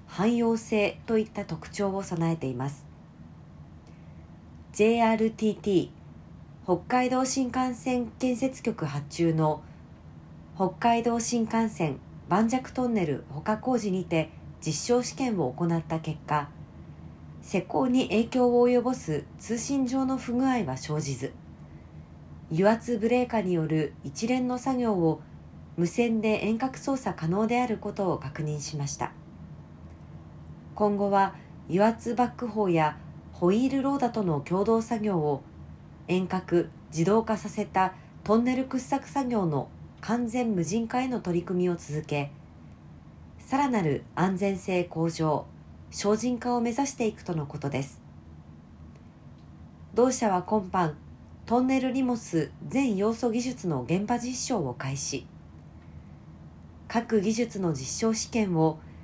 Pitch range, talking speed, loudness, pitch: 150-235 Hz, 240 characters per minute, -28 LUFS, 190 Hz